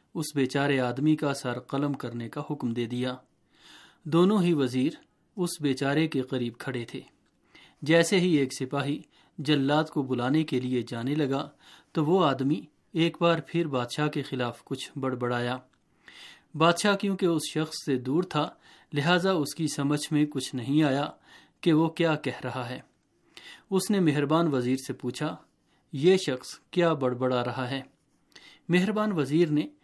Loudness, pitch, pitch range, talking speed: -27 LUFS, 145 Hz, 130-160 Hz, 160 wpm